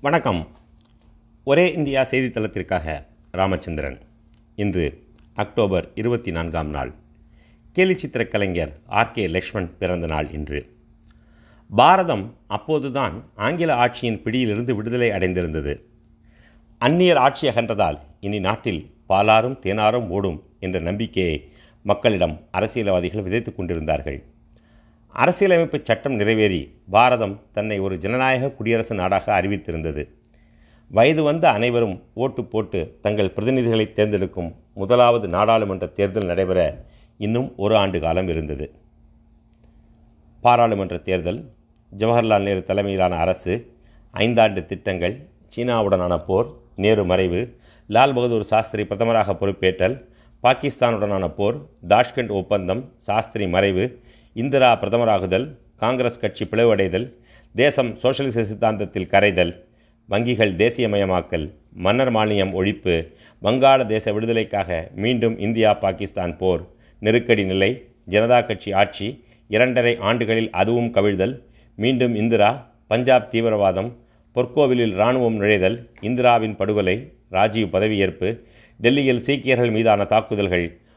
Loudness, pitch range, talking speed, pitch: -20 LUFS, 95-120 Hz, 100 wpm, 110 Hz